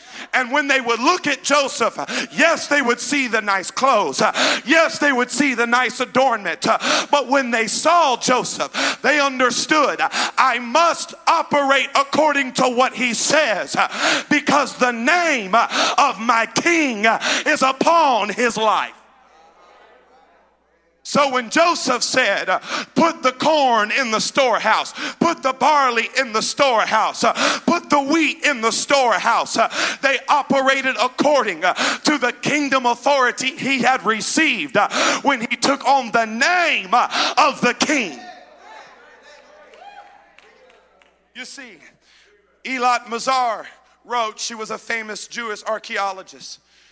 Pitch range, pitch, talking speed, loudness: 235-300 Hz, 265 Hz, 125 wpm, -17 LUFS